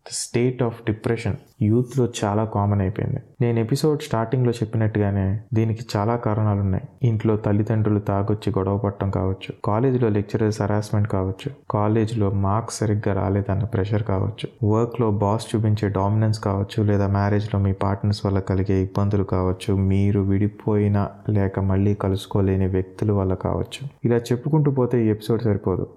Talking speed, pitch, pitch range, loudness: 150 wpm, 105 Hz, 100-115 Hz, -22 LUFS